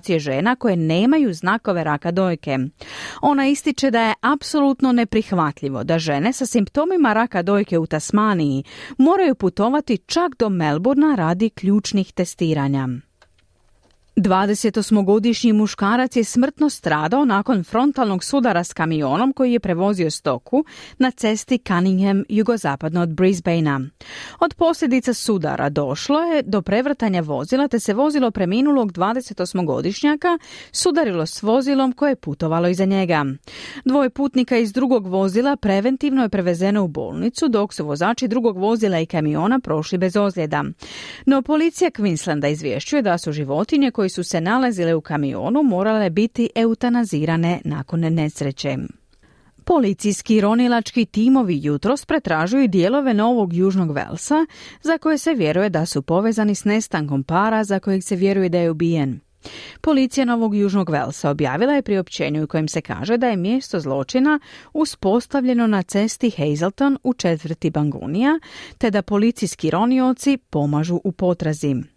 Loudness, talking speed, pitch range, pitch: -19 LUFS, 135 wpm, 165-255 Hz, 205 Hz